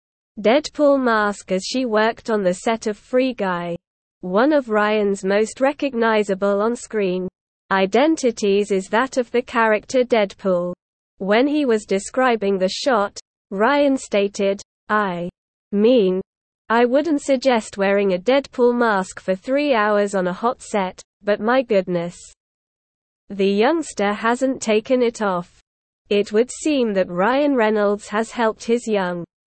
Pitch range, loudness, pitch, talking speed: 195-245 Hz, -19 LUFS, 215 Hz, 140 wpm